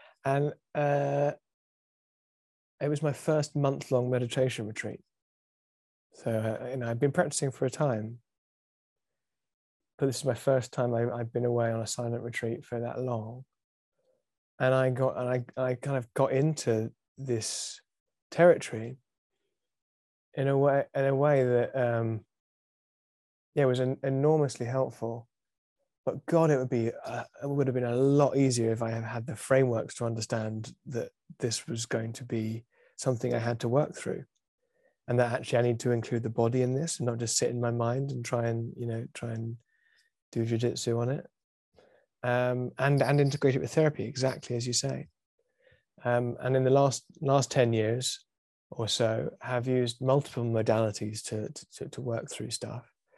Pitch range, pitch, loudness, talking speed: 115-135 Hz, 125 Hz, -30 LUFS, 175 wpm